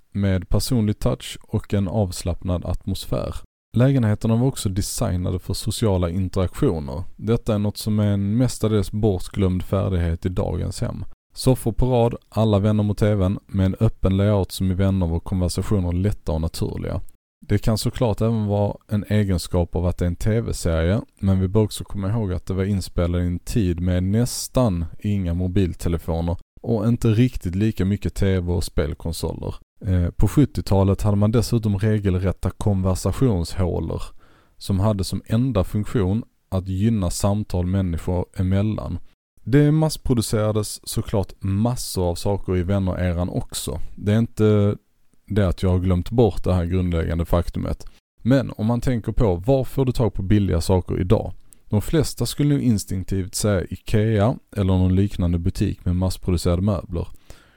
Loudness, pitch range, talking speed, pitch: -22 LUFS, 90-110 Hz, 155 wpm, 100 Hz